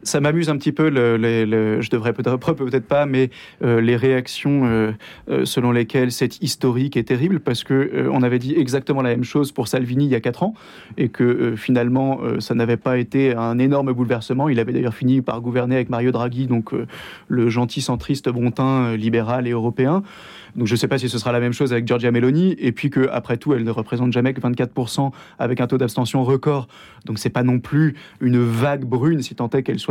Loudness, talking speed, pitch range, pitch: -20 LUFS, 230 wpm, 120-135 Hz, 125 Hz